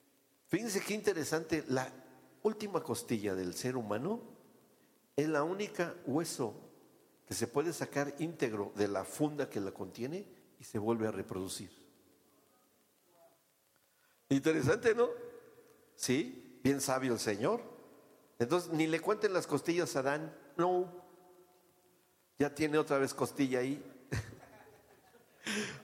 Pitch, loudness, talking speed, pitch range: 145 Hz, -36 LUFS, 120 wpm, 120-180 Hz